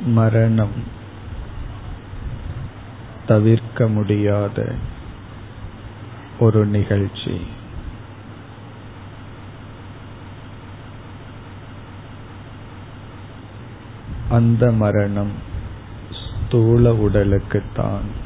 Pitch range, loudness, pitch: 100-115 Hz, -19 LUFS, 110 Hz